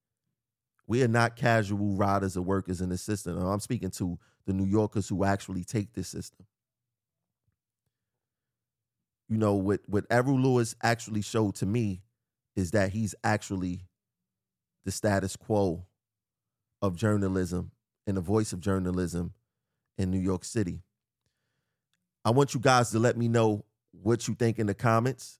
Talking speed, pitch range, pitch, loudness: 150 wpm, 95-120 Hz, 110 Hz, -29 LUFS